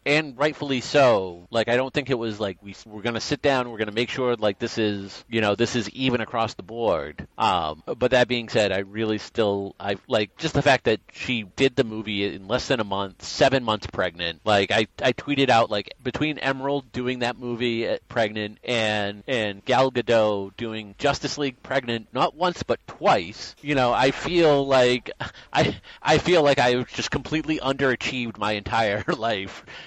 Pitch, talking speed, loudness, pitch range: 120 Hz, 195 wpm, -24 LUFS, 105-135 Hz